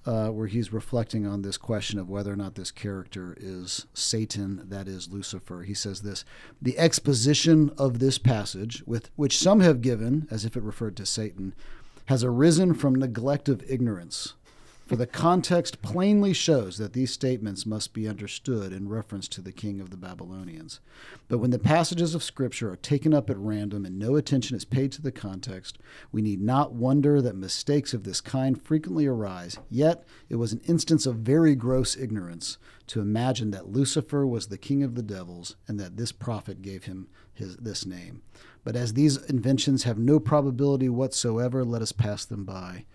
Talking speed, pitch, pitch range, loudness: 185 wpm, 115 Hz, 100-135 Hz, -26 LUFS